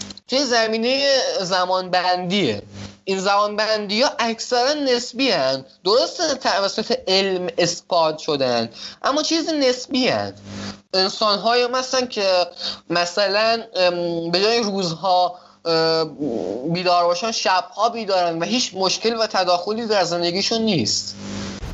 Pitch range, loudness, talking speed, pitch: 170-230 Hz, -20 LUFS, 105 wpm, 190 Hz